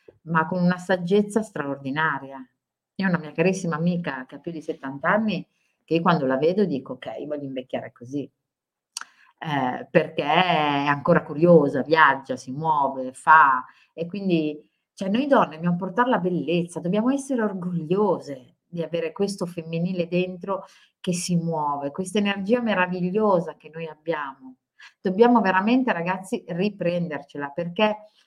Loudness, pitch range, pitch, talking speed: -23 LUFS, 155-195 Hz, 175 Hz, 140 wpm